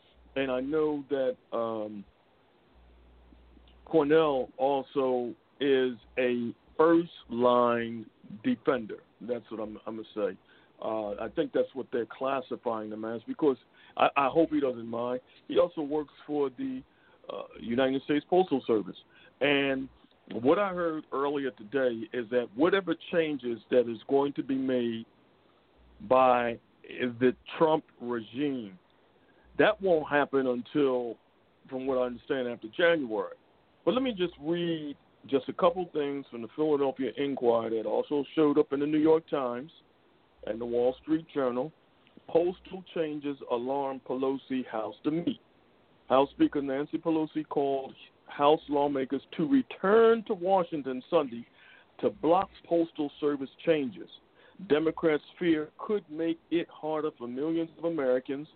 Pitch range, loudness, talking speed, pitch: 125-160 Hz, -29 LUFS, 140 wpm, 140 Hz